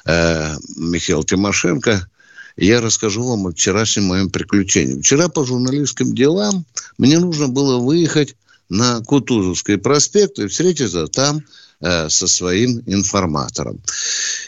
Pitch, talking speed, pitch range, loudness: 115 Hz, 110 wpm, 95-145 Hz, -16 LUFS